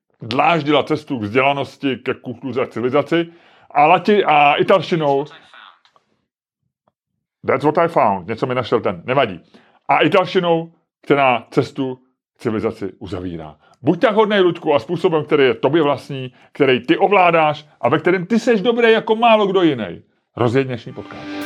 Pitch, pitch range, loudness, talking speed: 155 Hz, 130-190 Hz, -17 LUFS, 150 wpm